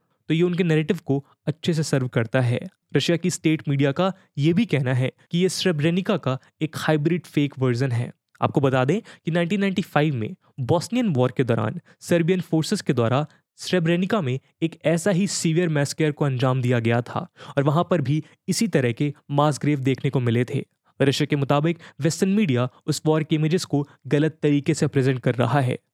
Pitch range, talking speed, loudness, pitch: 135-170 Hz, 195 wpm, -23 LUFS, 155 Hz